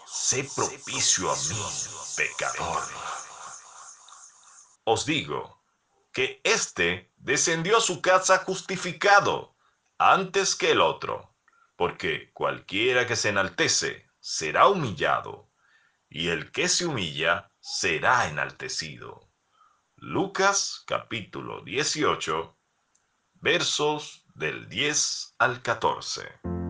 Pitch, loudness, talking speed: 195 Hz, -25 LUFS, 90 wpm